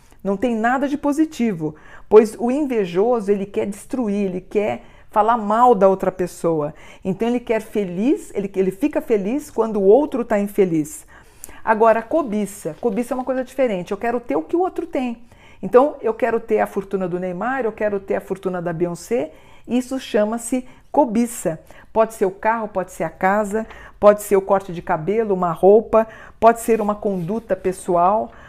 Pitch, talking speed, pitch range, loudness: 215 Hz, 180 wpm, 190-240 Hz, -20 LUFS